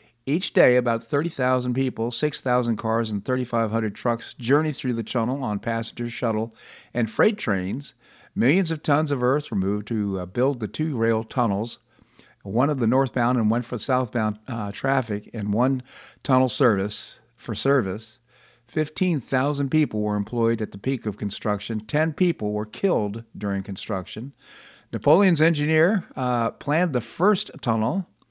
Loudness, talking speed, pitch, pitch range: -24 LUFS, 150 wpm, 120 Hz, 110-140 Hz